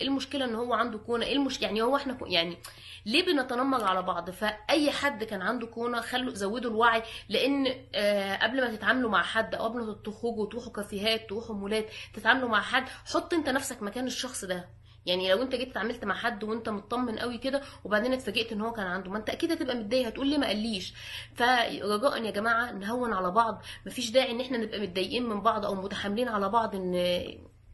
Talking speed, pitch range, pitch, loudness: 205 wpm, 205-250 Hz, 225 Hz, -29 LUFS